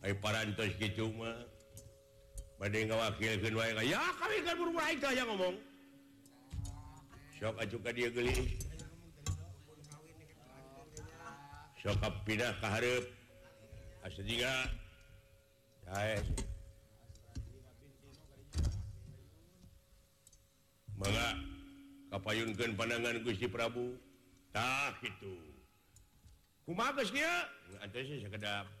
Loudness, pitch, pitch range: -38 LUFS, 110 Hz, 100-120 Hz